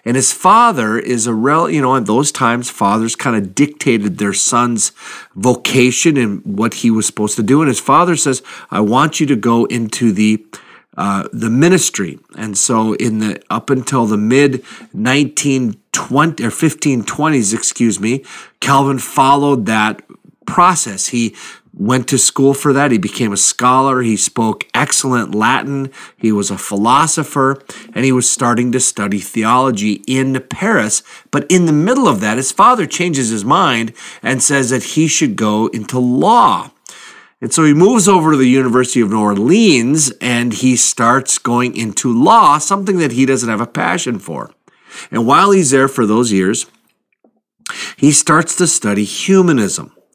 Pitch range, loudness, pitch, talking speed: 110-140 Hz, -13 LUFS, 125 Hz, 165 wpm